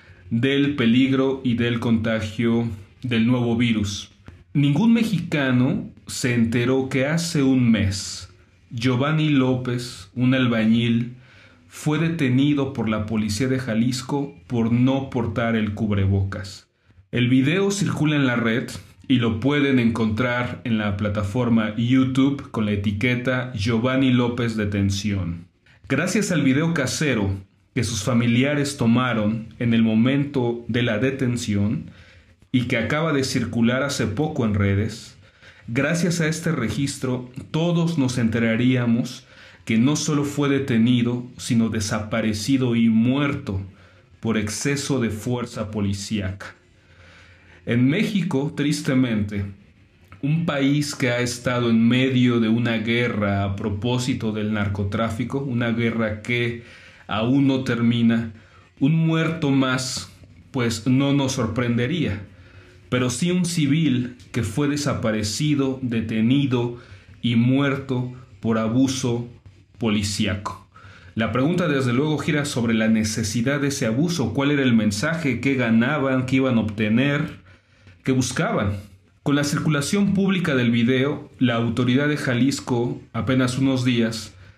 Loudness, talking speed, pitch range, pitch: -22 LUFS, 125 wpm, 110-135 Hz, 120 Hz